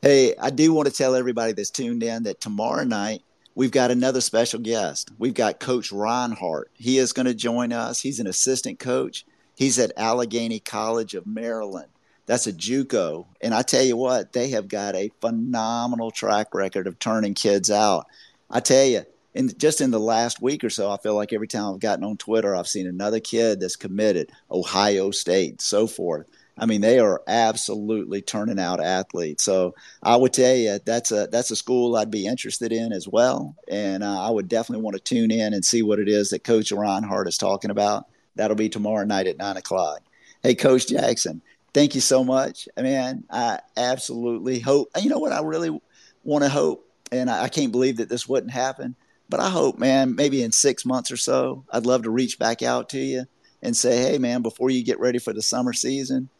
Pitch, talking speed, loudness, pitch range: 115 Hz, 210 wpm, -22 LUFS, 105-130 Hz